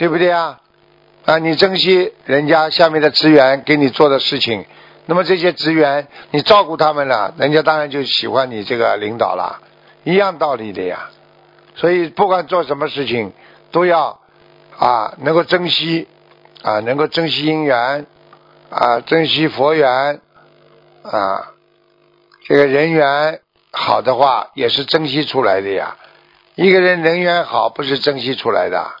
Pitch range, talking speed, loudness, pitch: 140-165 Hz, 225 characters per minute, -15 LUFS, 155 Hz